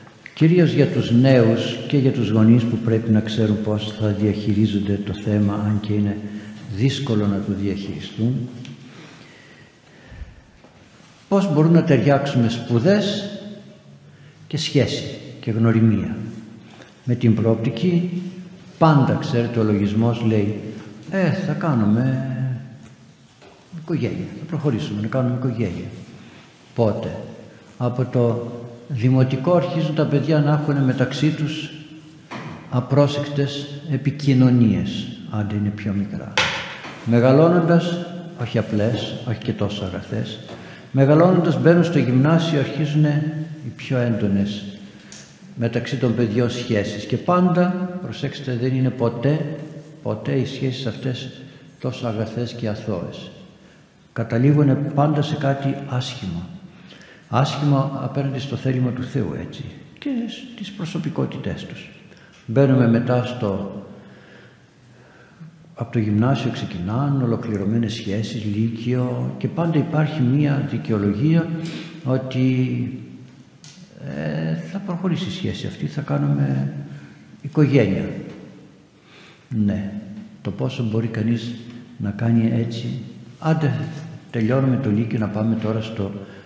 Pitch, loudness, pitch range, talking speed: 125 Hz, -21 LUFS, 110-150 Hz, 110 wpm